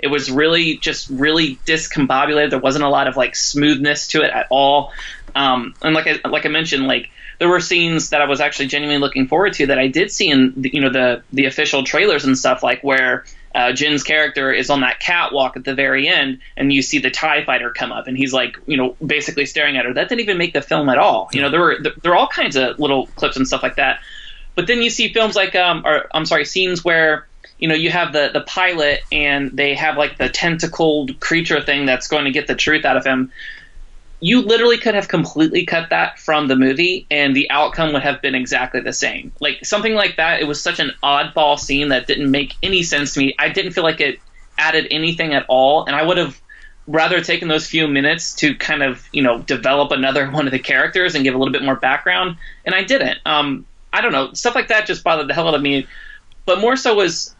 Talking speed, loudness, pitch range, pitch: 245 wpm, -16 LUFS, 140-170 Hz, 150 Hz